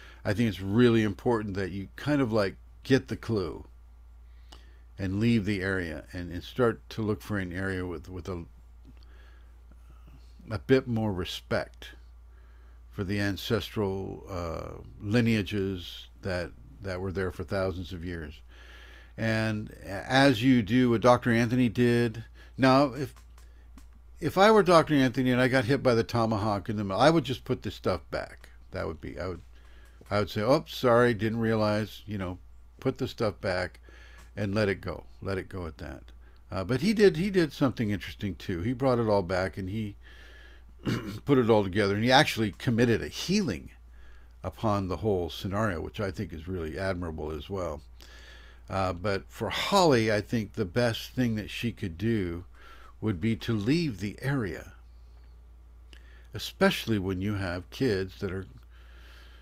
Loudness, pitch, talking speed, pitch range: -28 LUFS, 100 Hz, 170 wpm, 75-115 Hz